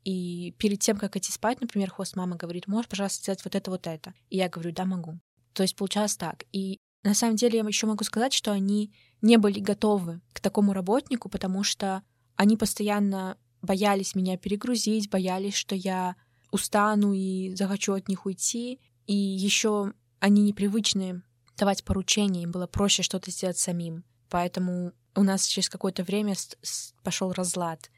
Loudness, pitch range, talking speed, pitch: -27 LUFS, 185-205 Hz, 165 wpm, 195 Hz